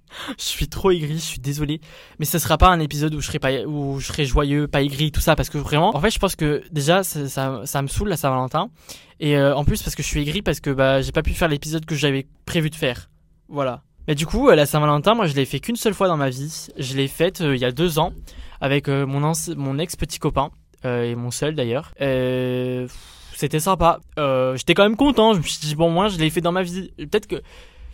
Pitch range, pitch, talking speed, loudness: 135-170 Hz, 150 Hz, 265 wpm, -21 LUFS